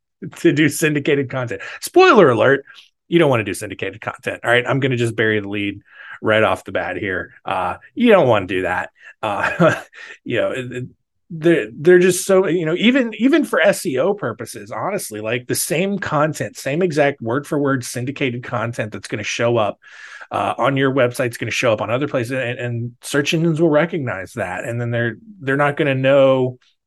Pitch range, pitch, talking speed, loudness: 120-160 Hz, 135 Hz, 205 wpm, -18 LUFS